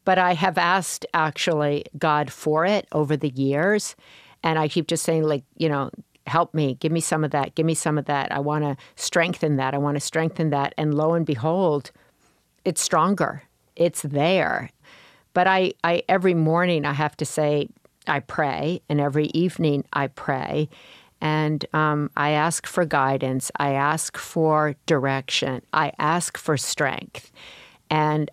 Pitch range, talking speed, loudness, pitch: 145-165 Hz, 170 wpm, -23 LUFS, 155 Hz